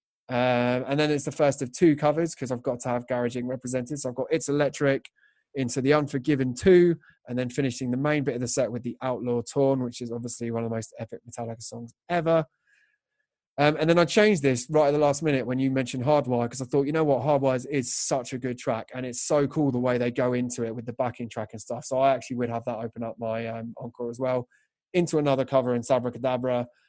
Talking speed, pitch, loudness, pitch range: 250 wpm, 130 Hz, -26 LUFS, 120-145 Hz